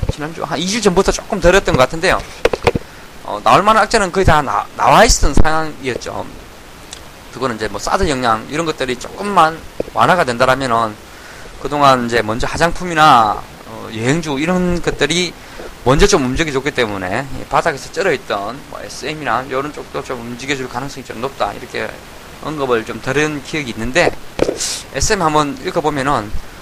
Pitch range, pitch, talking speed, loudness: 125-170 Hz, 145 Hz, 335 characters per minute, -16 LUFS